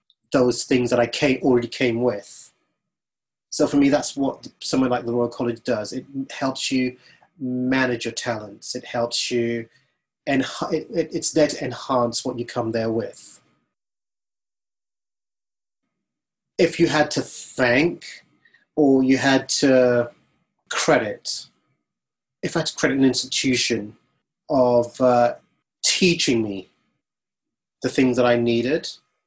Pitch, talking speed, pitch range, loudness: 125 Hz, 135 wpm, 120-135 Hz, -21 LUFS